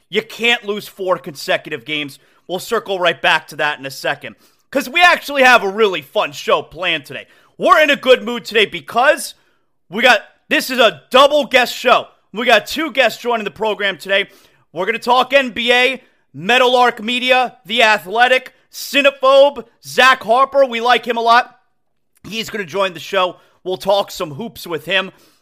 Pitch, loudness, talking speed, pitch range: 225 Hz, -15 LUFS, 180 wpm, 185-255 Hz